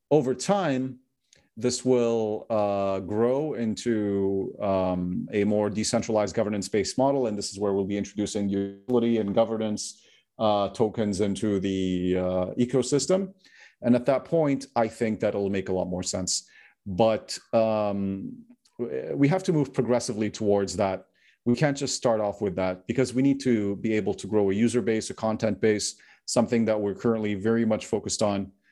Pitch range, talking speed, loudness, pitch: 100-125 Hz, 170 wpm, -26 LUFS, 110 Hz